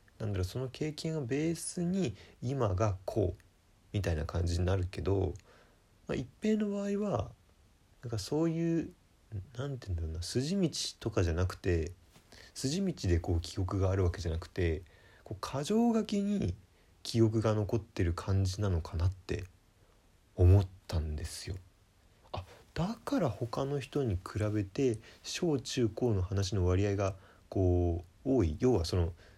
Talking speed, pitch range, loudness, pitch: 285 characters per minute, 90-125 Hz, -33 LUFS, 100 Hz